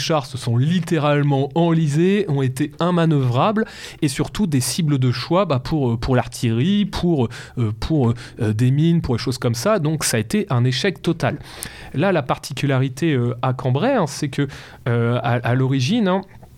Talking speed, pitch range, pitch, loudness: 180 wpm, 125-165 Hz, 140 Hz, -20 LUFS